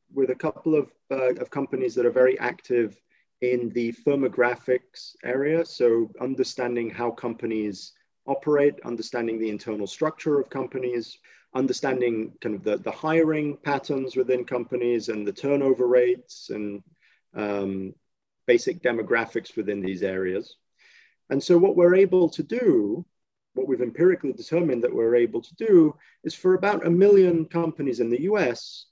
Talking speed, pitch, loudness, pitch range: 145 wpm, 130 Hz, -24 LUFS, 120-155 Hz